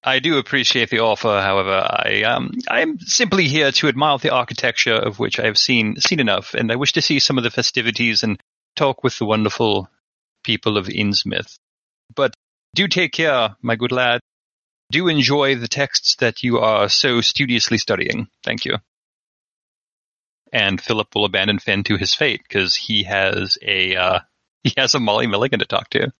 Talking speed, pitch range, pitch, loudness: 180 wpm, 110-140 Hz, 125 Hz, -17 LUFS